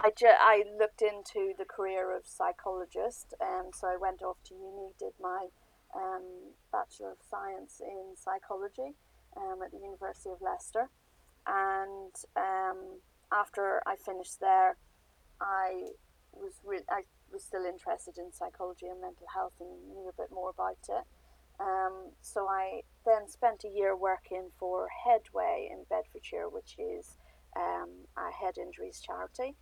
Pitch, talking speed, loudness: 200 Hz, 150 wpm, -34 LUFS